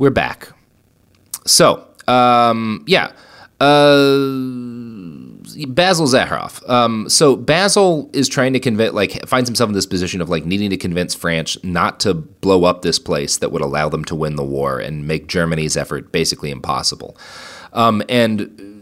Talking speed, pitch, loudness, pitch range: 155 wpm, 115 Hz, -16 LUFS, 90-130 Hz